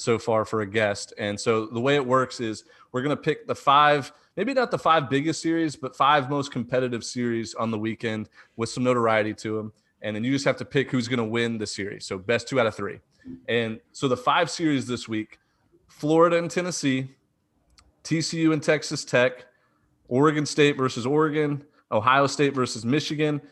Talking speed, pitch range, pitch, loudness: 200 wpm, 115-150 Hz, 130 Hz, -24 LUFS